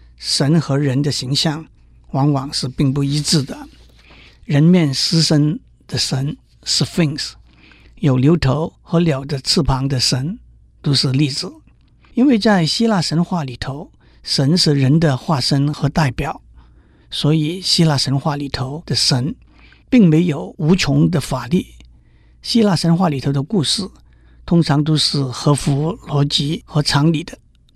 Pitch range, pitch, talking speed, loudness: 135-165 Hz, 145 Hz, 210 characters per minute, -17 LUFS